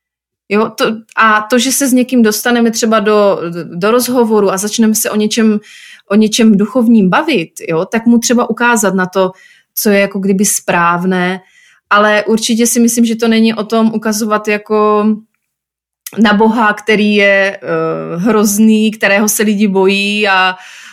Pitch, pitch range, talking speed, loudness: 215 Hz, 200-225 Hz, 165 wpm, -11 LUFS